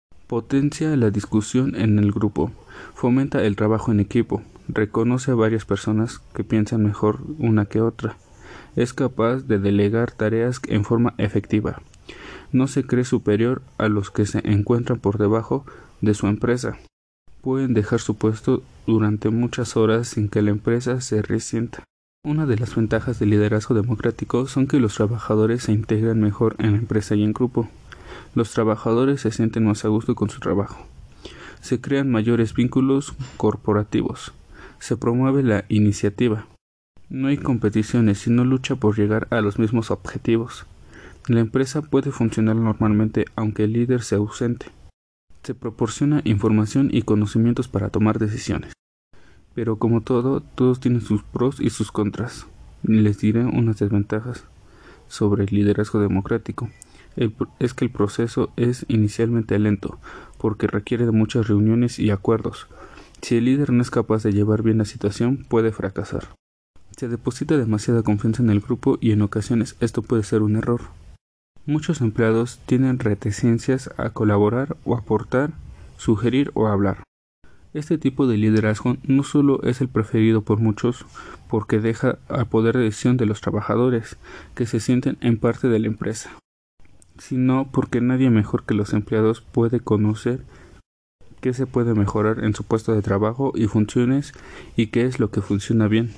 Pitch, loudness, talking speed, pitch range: 115 Hz, -21 LUFS, 155 wpm, 105-125 Hz